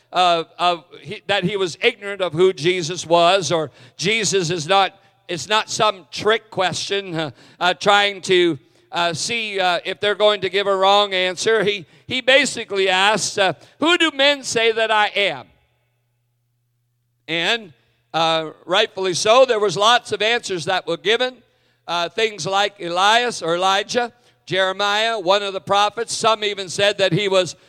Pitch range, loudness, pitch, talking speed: 170-210 Hz, -18 LUFS, 190 Hz, 165 wpm